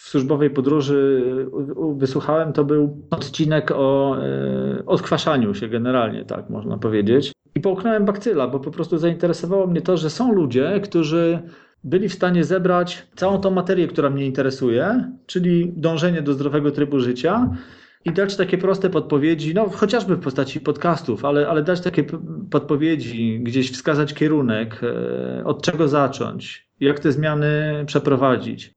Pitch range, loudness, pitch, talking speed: 135-175 Hz, -20 LUFS, 150 Hz, 140 wpm